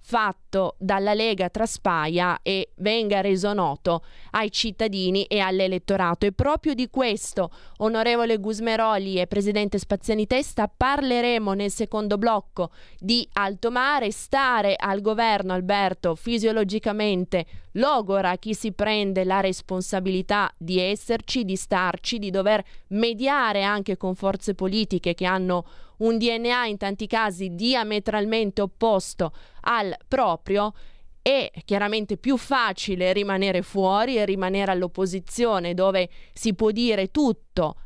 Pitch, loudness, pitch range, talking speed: 205 Hz, -24 LUFS, 190-225 Hz, 120 wpm